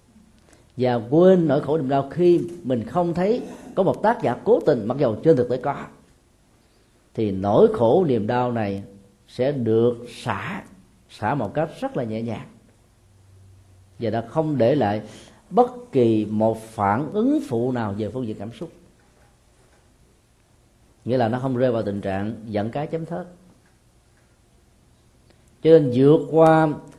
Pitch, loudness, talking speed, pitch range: 120 Hz, -21 LUFS, 160 wpm, 110-155 Hz